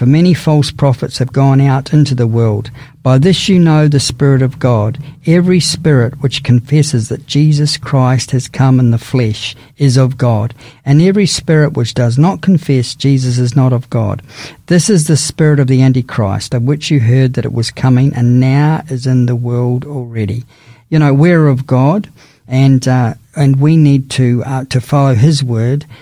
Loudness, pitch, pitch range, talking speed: -11 LUFS, 130 Hz, 125-145 Hz, 190 wpm